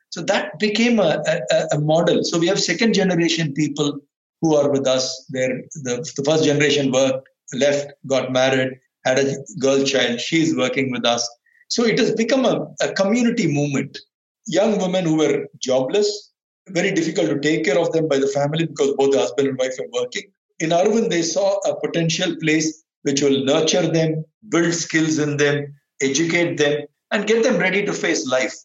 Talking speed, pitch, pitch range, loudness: 185 wpm, 155 Hz, 135-180 Hz, -19 LUFS